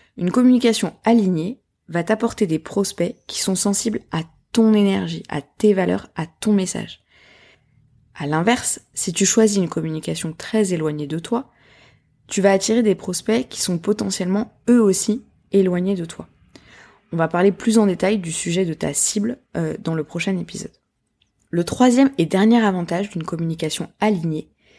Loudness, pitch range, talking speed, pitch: -20 LUFS, 165-215 Hz, 160 wpm, 190 Hz